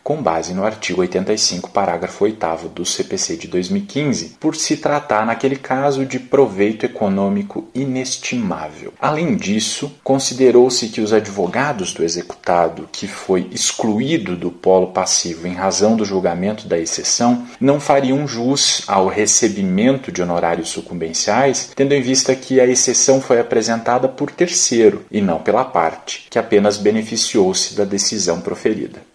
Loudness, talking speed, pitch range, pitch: -17 LUFS, 140 wpm, 100-135 Hz, 115 Hz